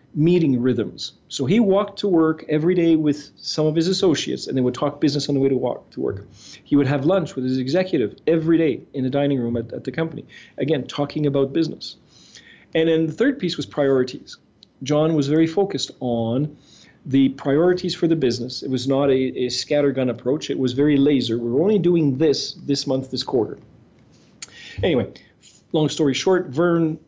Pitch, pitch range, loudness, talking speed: 145 Hz, 130-160 Hz, -21 LUFS, 195 wpm